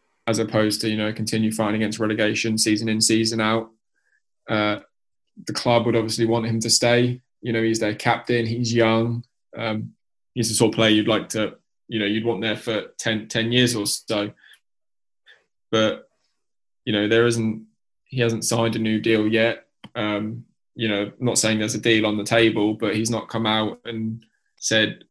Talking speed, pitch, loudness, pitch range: 190 wpm, 110 Hz, -22 LUFS, 110-115 Hz